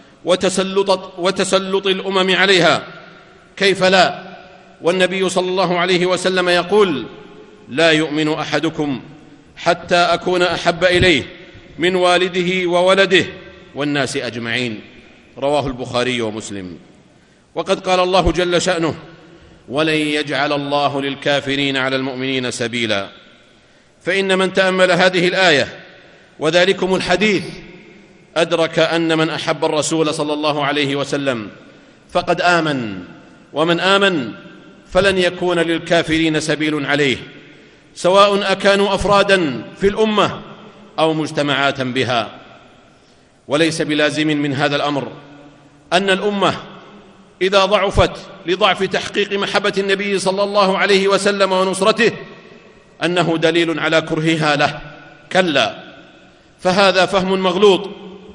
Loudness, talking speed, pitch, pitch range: -16 LUFS, 100 wpm, 175 Hz, 150-190 Hz